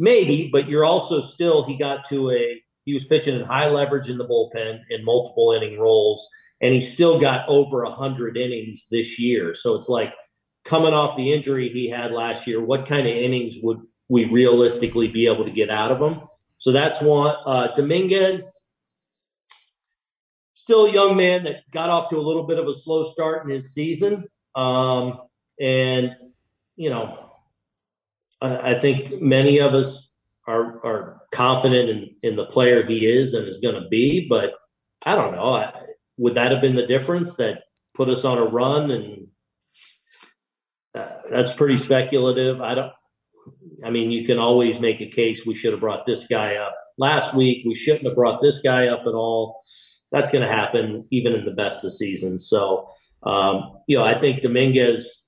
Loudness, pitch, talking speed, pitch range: -20 LUFS, 130 Hz, 185 wpm, 120-155 Hz